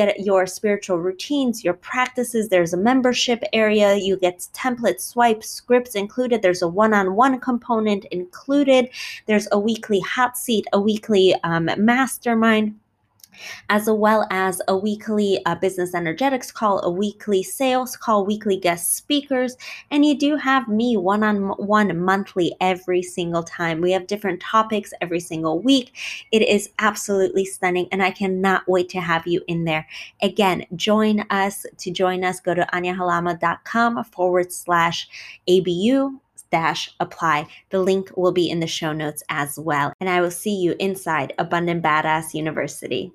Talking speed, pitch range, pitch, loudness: 155 wpm, 180-220 Hz, 195 Hz, -20 LUFS